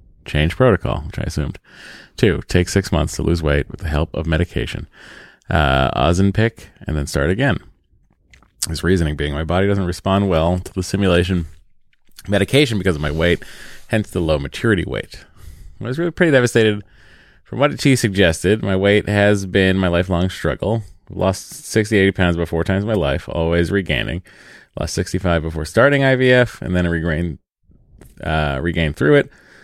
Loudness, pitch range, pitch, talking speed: -18 LUFS, 80-105 Hz, 95 Hz, 175 wpm